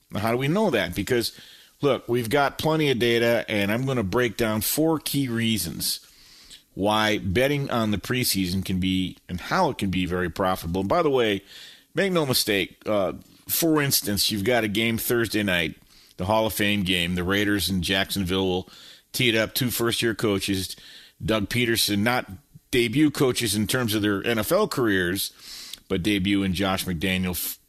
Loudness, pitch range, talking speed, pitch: -24 LUFS, 95-120 Hz, 180 wpm, 105 Hz